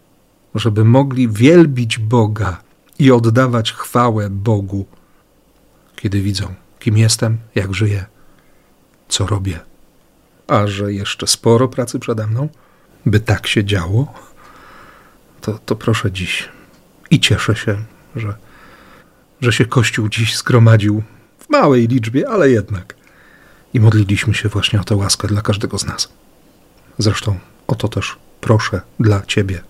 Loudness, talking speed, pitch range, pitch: -15 LUFS, 125 wpm, 100-120 Hz, 110 Hz